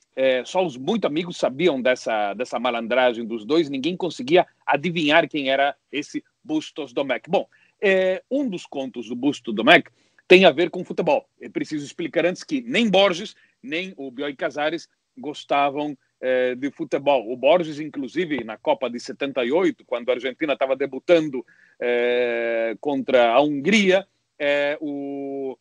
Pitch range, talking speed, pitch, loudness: 130-185 Hz, 150 wpm, 150 Hz, -22 LUFS